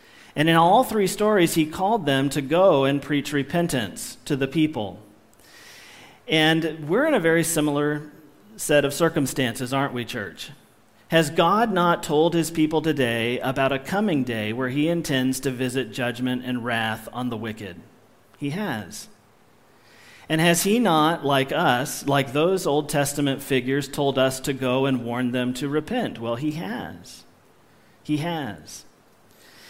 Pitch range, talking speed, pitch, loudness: 130-165 Hz, 155 wpm, 145 Hz, -23 LUFS